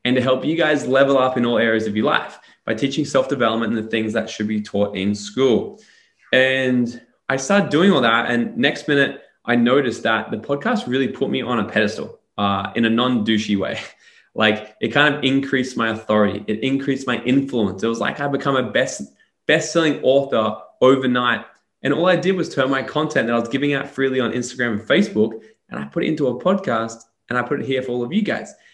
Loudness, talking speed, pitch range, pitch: -19 LUFS, 220 wpm, 110-140 Hz, 125 Hz